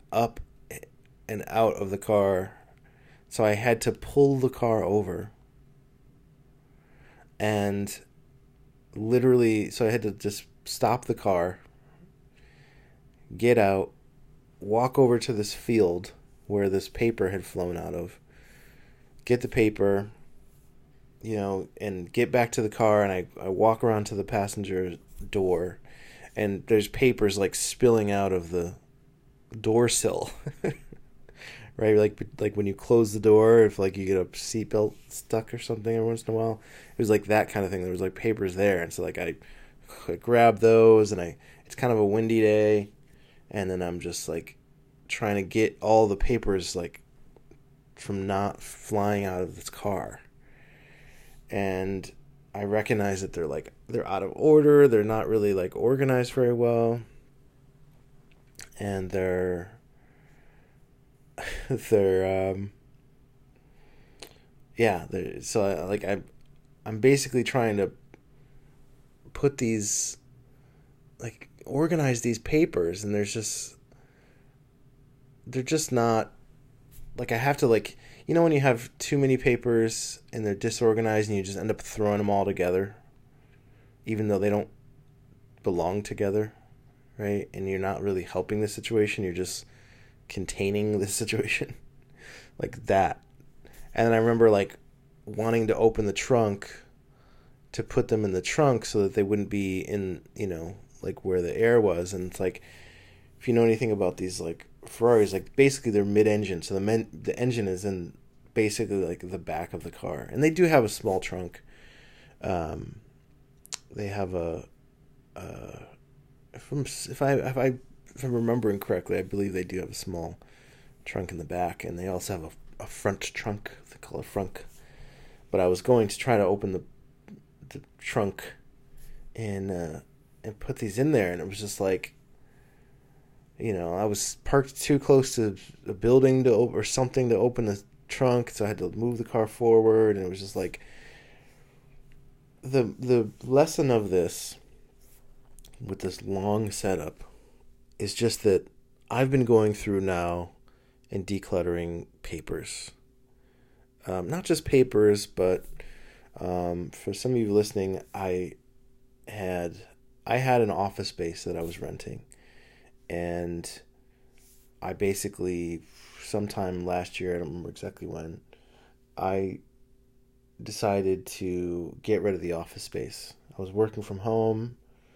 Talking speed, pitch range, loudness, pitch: 150 wpm, 100-130 Hz, -27 LUFS, 115 Hz